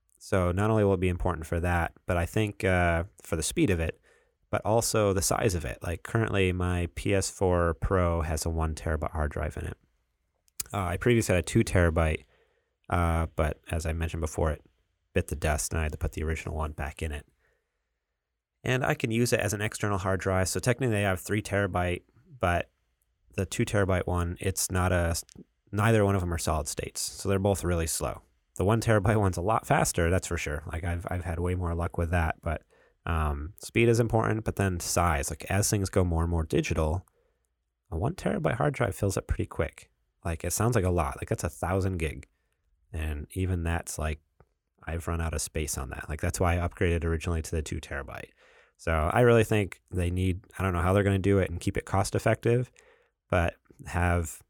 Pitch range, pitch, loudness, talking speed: 80-100 Hz, 90 Hz, -29 LUFS, 220 wpm